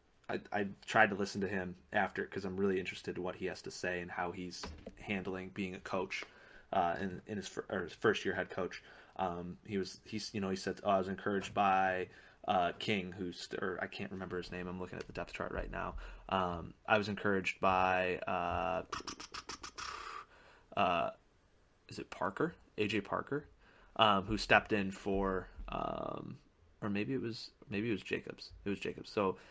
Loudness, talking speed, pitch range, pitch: -37 LUFS, 195 wpm, 90-100 Hz, 95 Hz